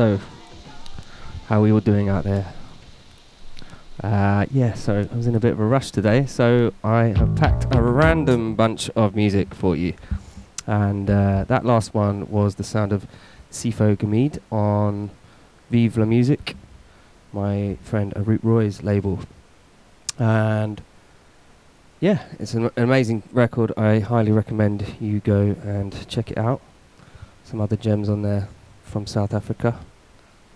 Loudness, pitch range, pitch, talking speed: -21 LUFS, 100-115 Hz, 105 Hz, 145 wpm